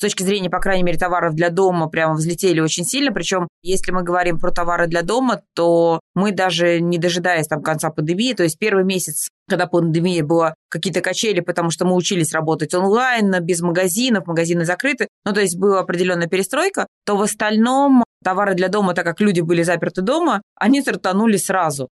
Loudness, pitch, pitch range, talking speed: -18 LUFS, 180 Hz, 170-200 Hz, 190 wpm